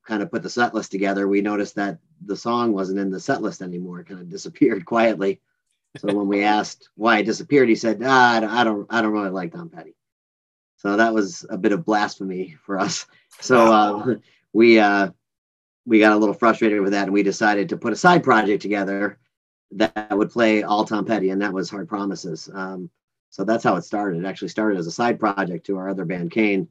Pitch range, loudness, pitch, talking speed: 95-110 Hz, -20 LUFS, 100 Hz, 225 wpm